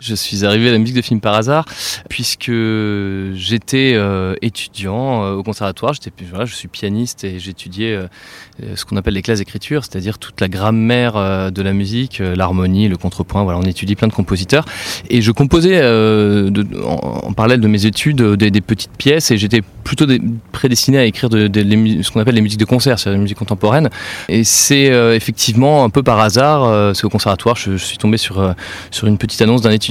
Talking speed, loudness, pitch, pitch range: 220 wpm, -14 LUFS, 110 Hz, 100-120 Hz